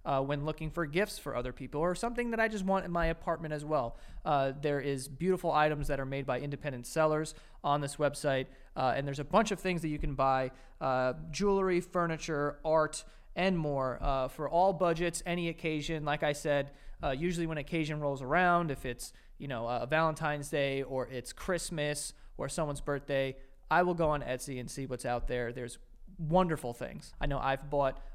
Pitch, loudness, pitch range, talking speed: 150 Hz, -33 LUFS, 135-165 Hz, 205 wpm